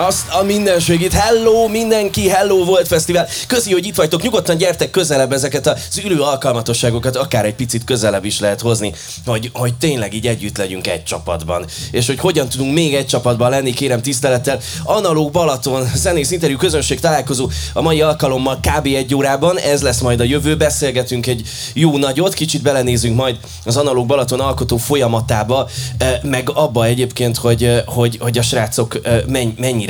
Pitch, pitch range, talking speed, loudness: 130 Hz, 120-150 Hz, 165 wpm, -15 LUFS